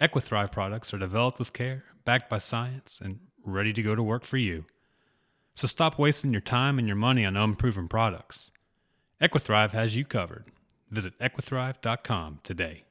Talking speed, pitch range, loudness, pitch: 165 wpm, 105-130 Hz, -28 LUFS, 115 Hz